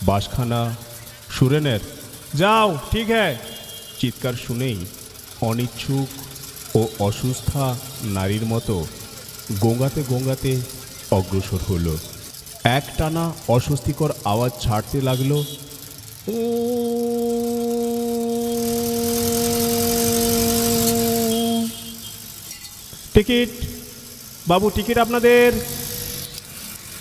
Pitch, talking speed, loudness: 135 Hz, 60 wpm, -21 LUFS